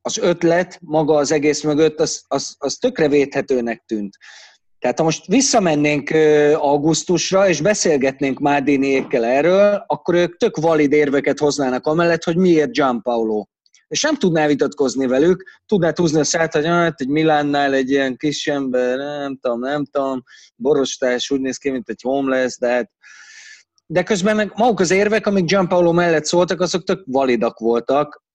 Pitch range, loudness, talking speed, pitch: 135-175 Hz, -17 LUFS, 165 wpm, 150 Hz